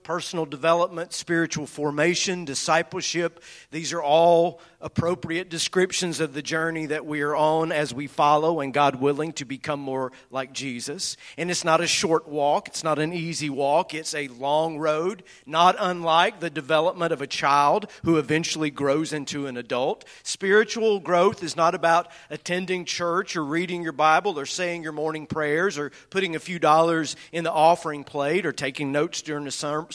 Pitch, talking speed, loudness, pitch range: 160 Hz, 175 wpm, -24 LUFS, 150-170 Hz